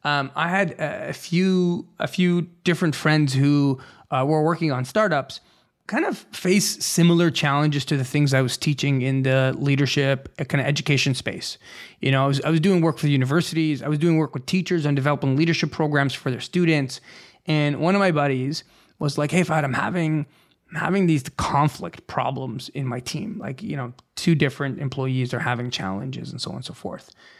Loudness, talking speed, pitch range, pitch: -22 LUFS, 200 wpm, 135-165 Hz, 150 Hz